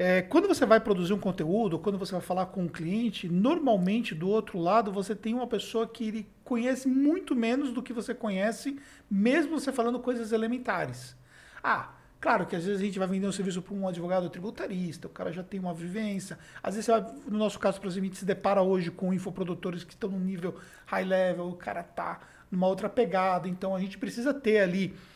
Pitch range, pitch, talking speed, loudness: 185-230 Hz, 195 Hz, 205 wpm, -30 LUFS